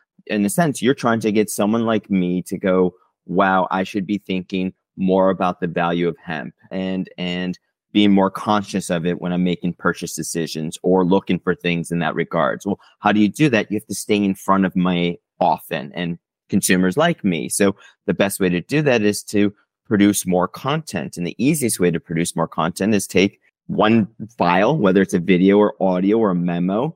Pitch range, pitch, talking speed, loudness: 90-105 Hz, 95 Hz, 210 wpm, -19 LUFS